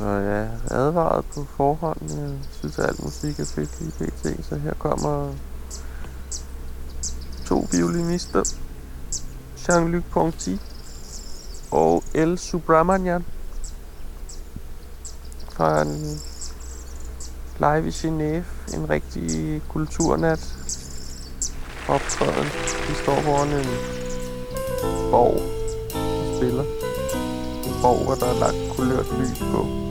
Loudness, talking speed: -24 LUFS, 100 wpm